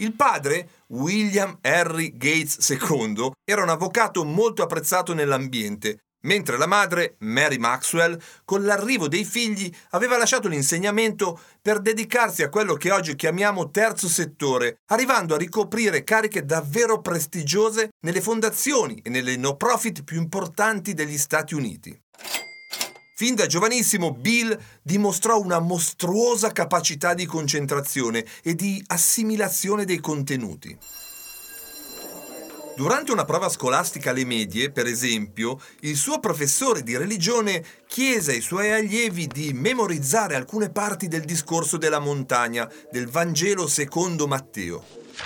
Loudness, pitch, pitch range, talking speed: -22 LUFS, 175 Hz, 150-215 Hz, 125 wpm